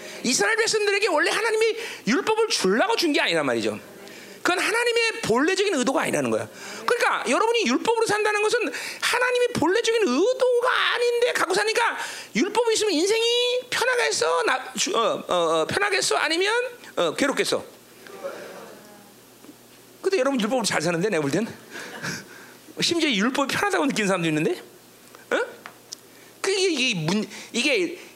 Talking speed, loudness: 340 characters per minute, -22 LUFS